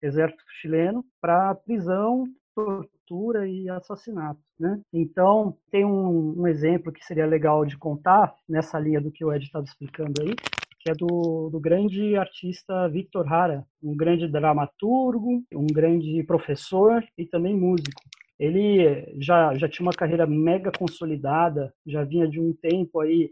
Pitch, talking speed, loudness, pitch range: 170 Hz, 150 wpm, -24 LUFS, 155-190 Hz